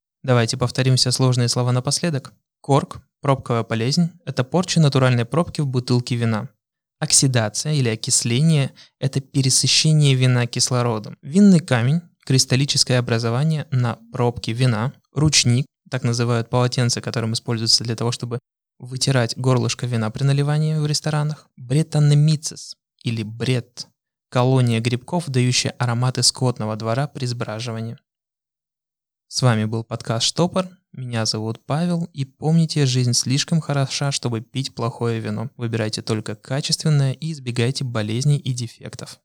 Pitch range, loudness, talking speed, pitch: 120-145 Hz, -20 LUFS, 125 wpm, 130 Hz